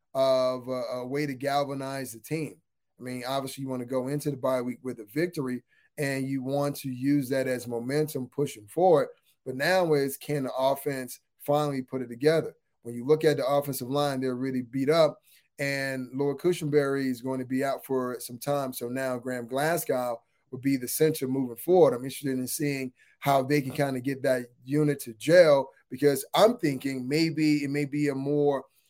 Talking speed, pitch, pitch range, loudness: 200 wpm, 135 Hz, 130-145 Hz, -28 LUFS